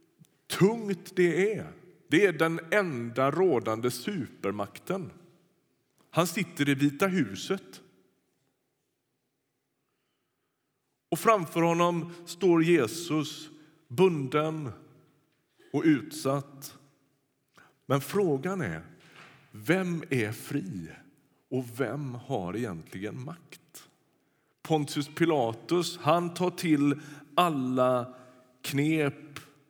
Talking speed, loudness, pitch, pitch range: 80 wpm, -29 LUFS, 155 Hz, 135-175 Hz